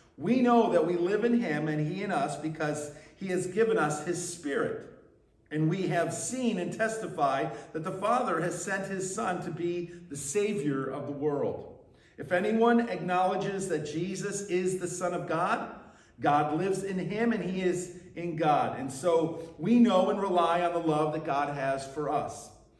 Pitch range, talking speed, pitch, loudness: 155-195 Hz, 185 wpm, 175 Hz, -29 LUFS